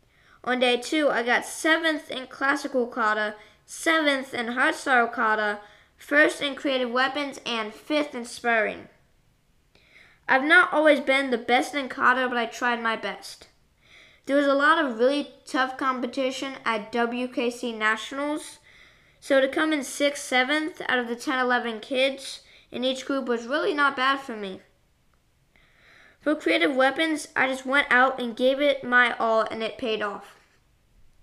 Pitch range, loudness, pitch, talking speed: 235-285 Hz, -24 LUFS, 260 Hz, 155 wpm